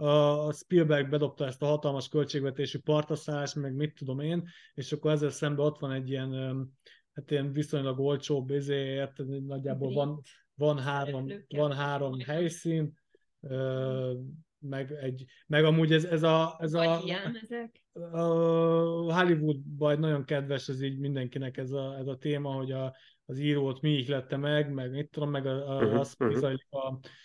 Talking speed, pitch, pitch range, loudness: 150 wpm, 145 Hz, 135-150 Hz, -31 LUFS